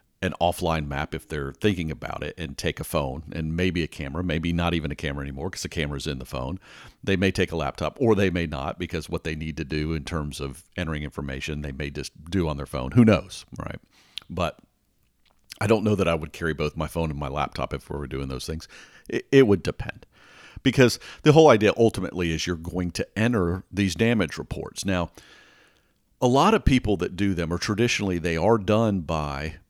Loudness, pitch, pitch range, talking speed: -25 LUFS, 85 Hz, 75-95 Hz, 220 wpm